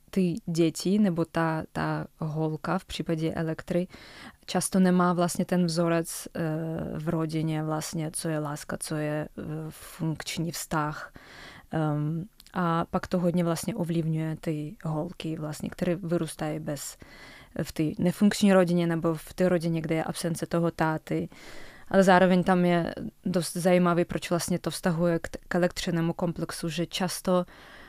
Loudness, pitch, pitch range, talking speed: -28 LUFS, 170 Hz, 160-180 Hz, 140 wpm